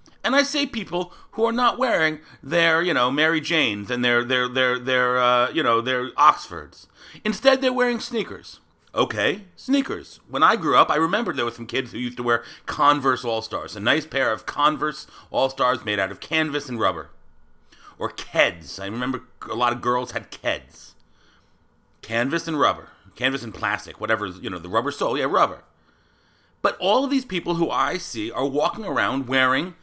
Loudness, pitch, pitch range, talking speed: -22 LUFS, 130 Hz, 120-170 Hz, 190 wpm